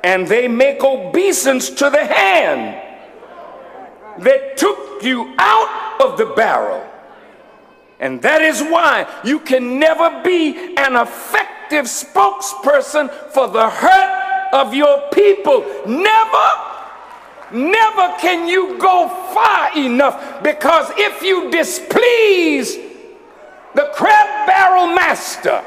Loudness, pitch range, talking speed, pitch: -14 LUFS, 275-385 Hz, 110 wpm, 325 Hz